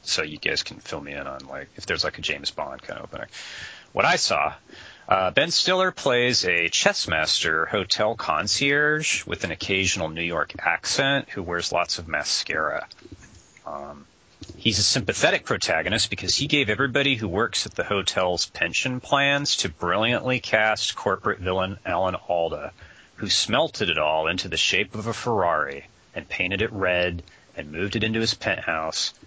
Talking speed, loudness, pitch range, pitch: 170 wpm, -23 LUFS, 85-125 Hz, 100 Hz